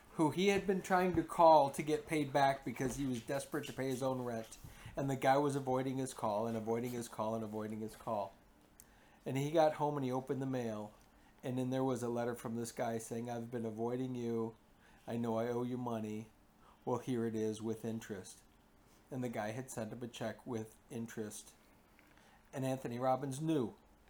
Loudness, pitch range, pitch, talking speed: -38 LUFS, 110-135 Hz, 120 Hz, 210 wpm